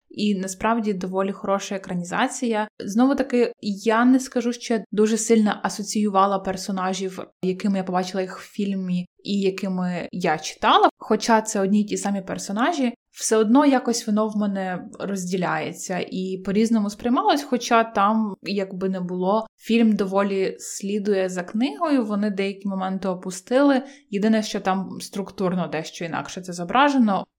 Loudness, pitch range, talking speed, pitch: -23 LUFS, 190-230 Hz, 140 wpm, 205 Hz